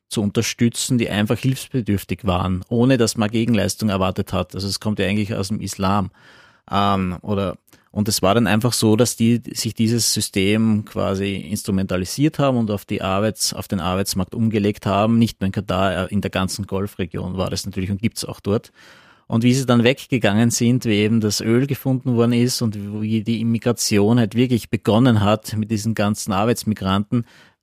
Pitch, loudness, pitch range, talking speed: 105 Hz, -20 LUFS, 100-115 Hz, 185 wpm